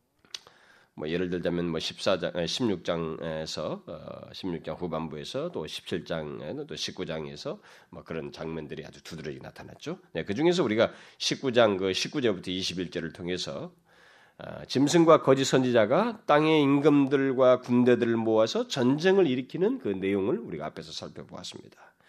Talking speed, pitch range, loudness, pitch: 300 characters per minute, 85-145 Hz, -27 LUFS, 115 Hz